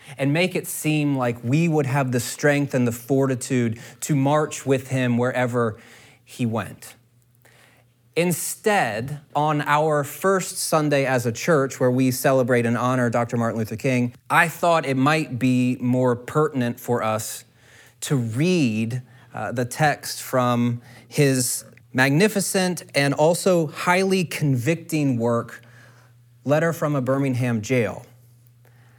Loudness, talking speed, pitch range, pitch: -22 LUFS, 130 wpm, 120-150 Hz, 130 Hz